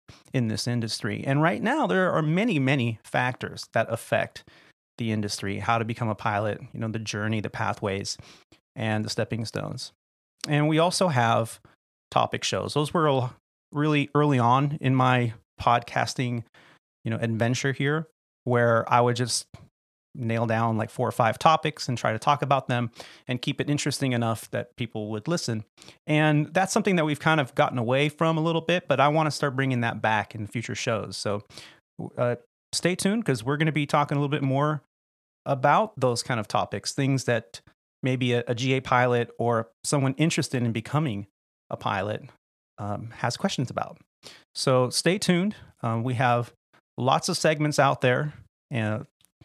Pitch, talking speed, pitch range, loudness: 125 Hz, 180 wpm, 115-145 Hz, -26 LUFS